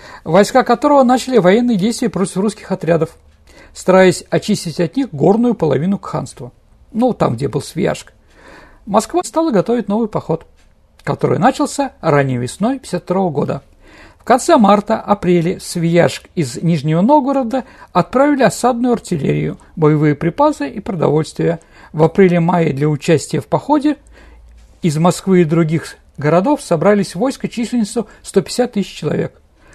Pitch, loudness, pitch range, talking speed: 185 Hz, -15 LUFS, 165-235 Hz, 130 wpm